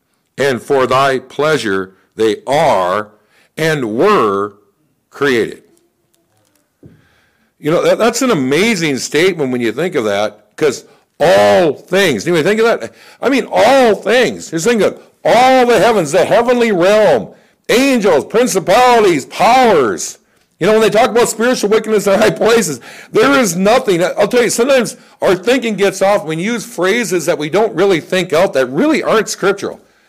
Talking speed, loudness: 160 wpm, -12 LUFS